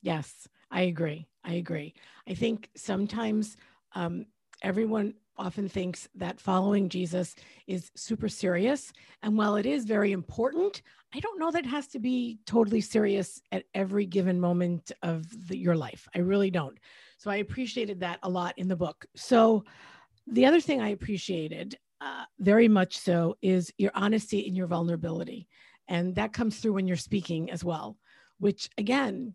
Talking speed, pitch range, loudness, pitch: 165 wpm, 180-225 Hz, -29 LUFS, 200 Hz